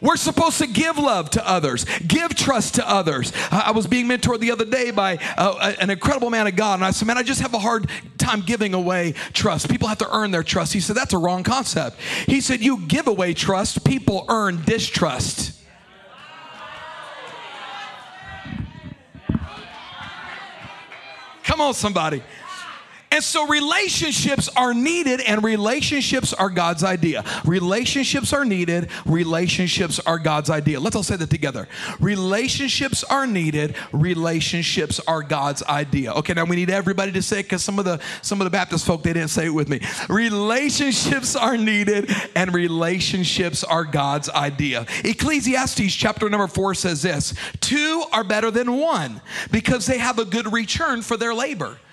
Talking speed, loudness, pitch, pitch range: 165 wpm, -20 LUFS, 205 Hz, 170-245 Hz